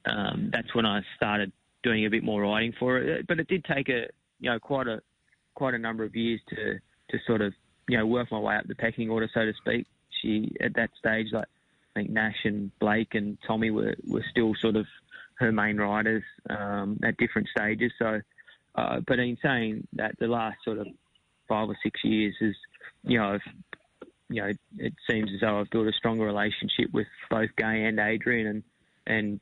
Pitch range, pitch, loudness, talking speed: 105-115 Hz, 110 Hz, -28 LUFS, 210 wpm